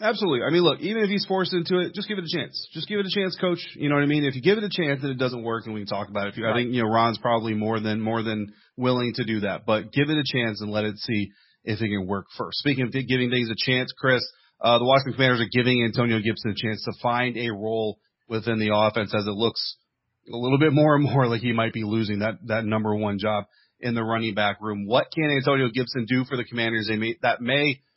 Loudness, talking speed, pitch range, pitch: -24 LUFS, 280 wpm, 110-140 Hz, 120 Hz